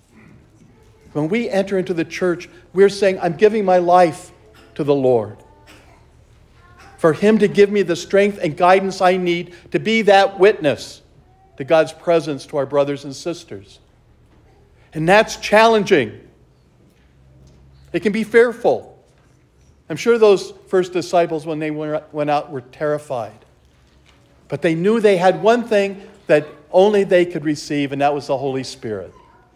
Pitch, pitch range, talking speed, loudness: 170 Hz, 145-195 Hz, 150 wpm, -17 LUFS